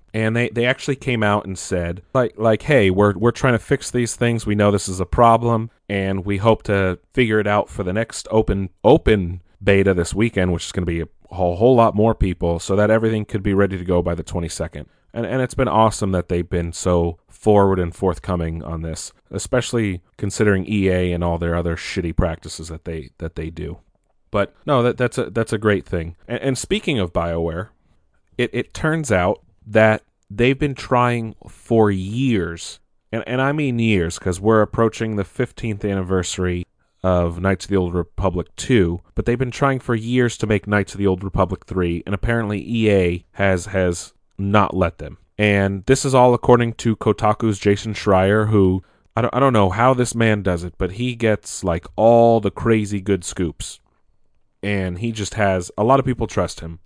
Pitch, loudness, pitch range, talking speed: 100 Hz, -19 LUFS, 90-115 Hz, 205 wpm